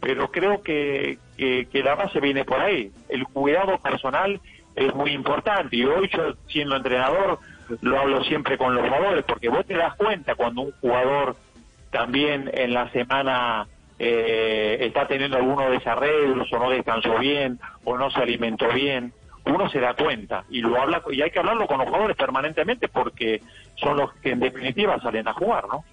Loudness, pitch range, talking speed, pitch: -23 LUFS, 120-140 Hz, 180 wpm, 130 Hz